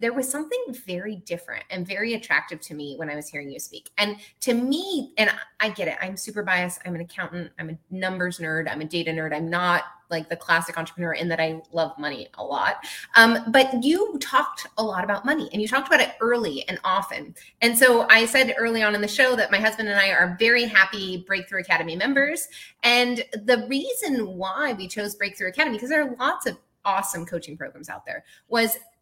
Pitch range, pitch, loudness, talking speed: 175-245 Hz, 205 Hz, -22 LUFS, 215 wpm